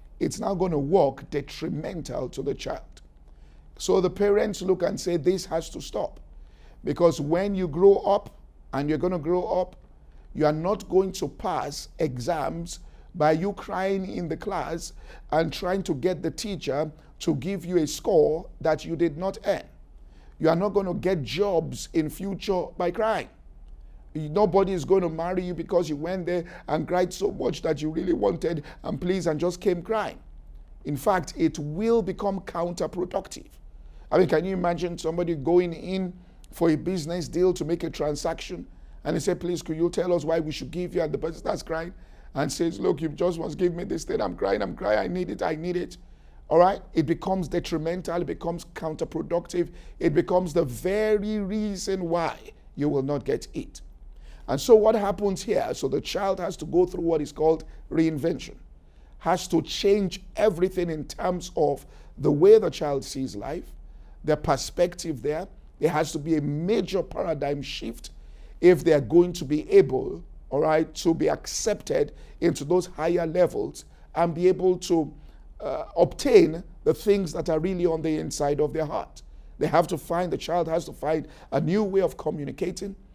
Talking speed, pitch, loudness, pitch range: 190 wpm, 170 Hz, -26 LUFS, 155-185 Hz